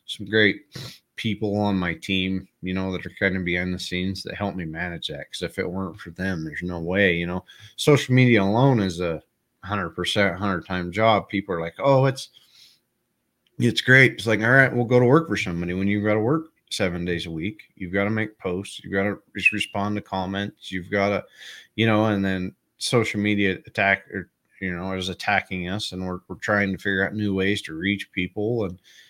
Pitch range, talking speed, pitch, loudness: 90-110 Hz, 225 wpm, 100 Hz, -23 LUFS